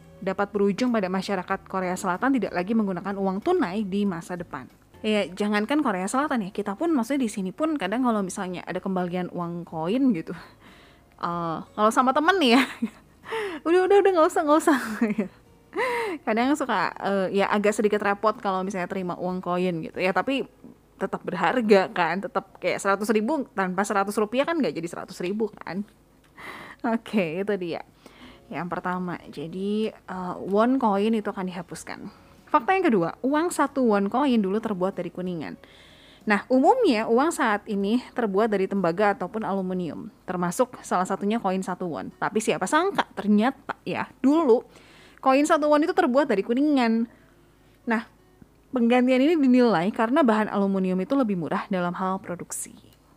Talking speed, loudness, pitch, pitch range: 165 wpm, -24 LUFS, 210 Hz, 185-255 Hz